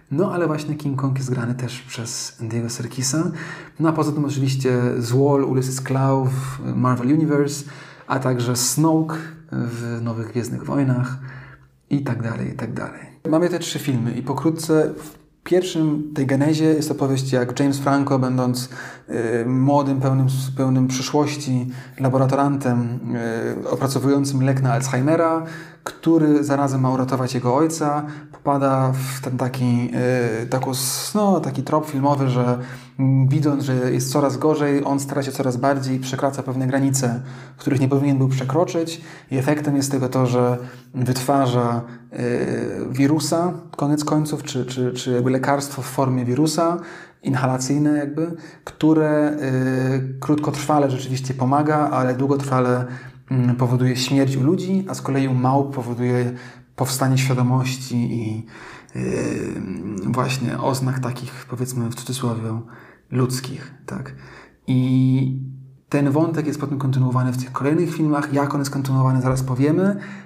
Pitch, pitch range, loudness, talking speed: 135 Hz, 125-145 Hz, -21 LUFS, 135 wpm